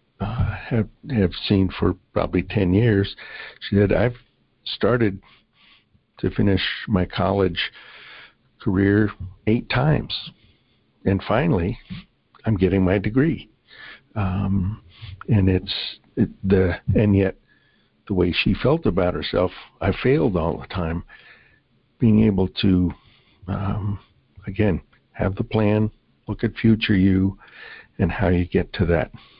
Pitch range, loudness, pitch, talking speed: 95-110 Hz, -22 LUFS, 100 Hz, 125 wpm